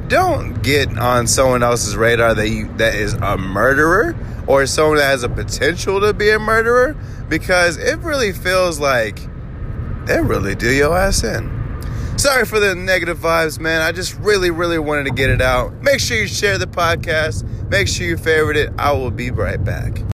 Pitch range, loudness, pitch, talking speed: 110-160 Hz, -16 LUFS, 125 Hz, 190 wpm